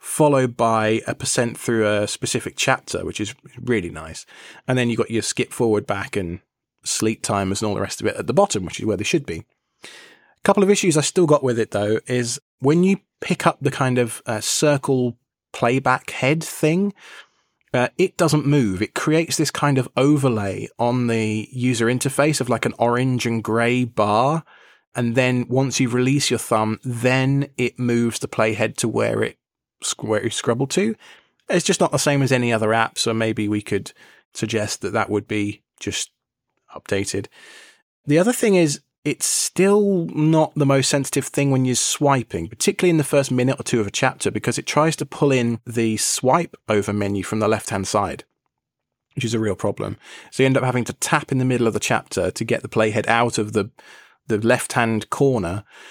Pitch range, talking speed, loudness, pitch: 110-145 Hz, 205 wpm, -20 LUFS, 125 Hz